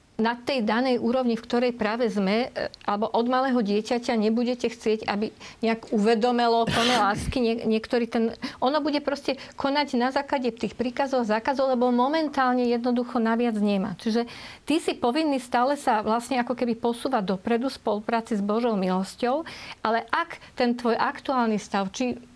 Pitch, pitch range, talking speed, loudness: 240 Hz, 225-255 Hz, 160 wpm, -25 LUFS